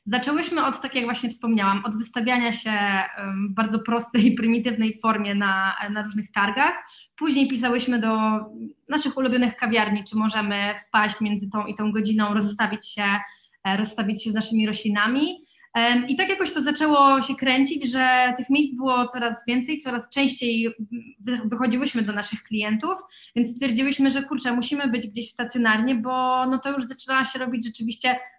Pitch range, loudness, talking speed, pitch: 215-260 Hz, -23 LUFS, 155 wpm, 240 Hz